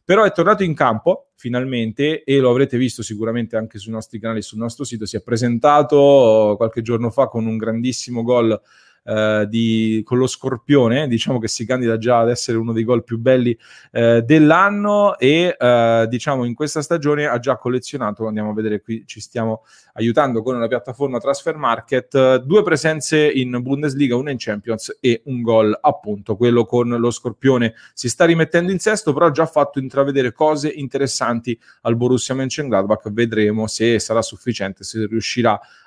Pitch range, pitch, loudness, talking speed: 115-140 Hz, 120 Hz, -17 LUFS, 175 wpm